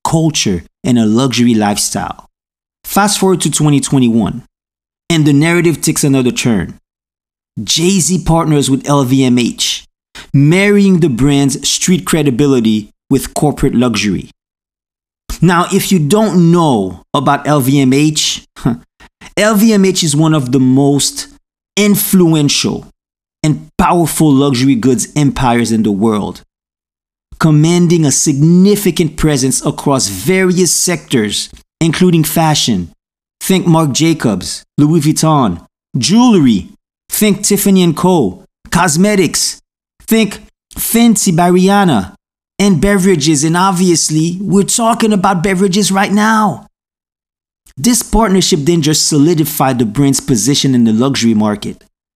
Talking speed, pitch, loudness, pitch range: 110 wpm, 160 Hz, -11 LUFS, 135-185 Hz